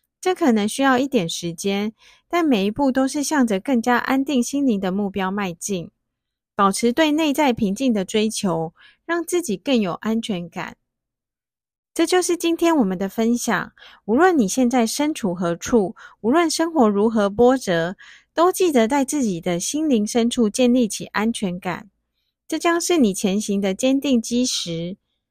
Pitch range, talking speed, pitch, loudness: 195-275 Hz, 240 characters per minute, 235 Hz, -20 LUFS